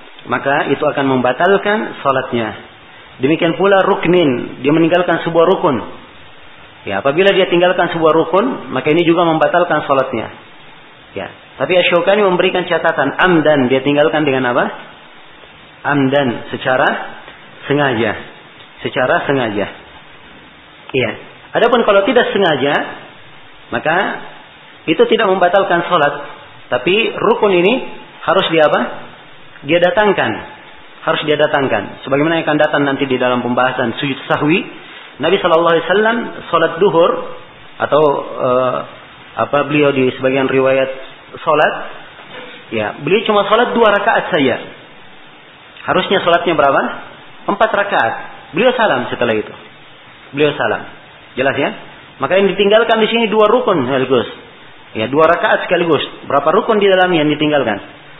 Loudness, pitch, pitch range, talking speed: -14 LUFS, 150 Hz, 135-180 Hz, 125 wpm